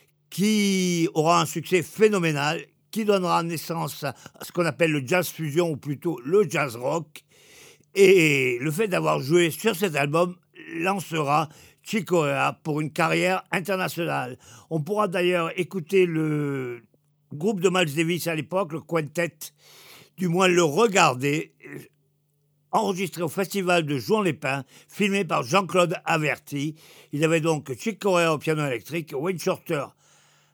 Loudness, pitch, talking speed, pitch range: -24 LUFS, 170 Hz, 140 wpm, 150-190 Hz